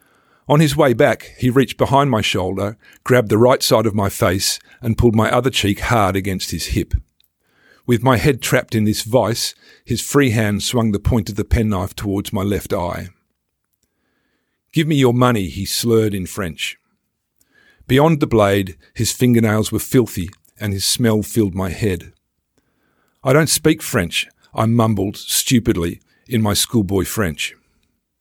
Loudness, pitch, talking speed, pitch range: -17 LUFS, 110 Hz, 165 wpm, 100-125 Hz